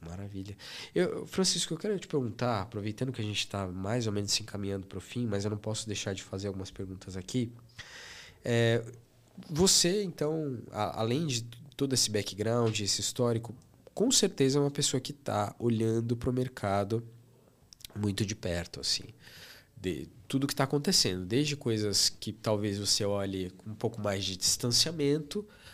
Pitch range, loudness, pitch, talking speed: 100-130 Hz, -31 LUFS, 115 Hz, 170 wpm